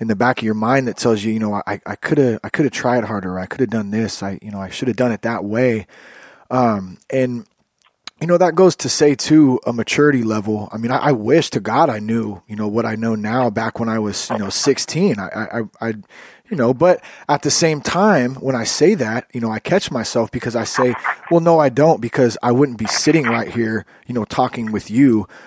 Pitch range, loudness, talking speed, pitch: 110-135 Hz, -17 LUFS, 250 wpm, 115 Hz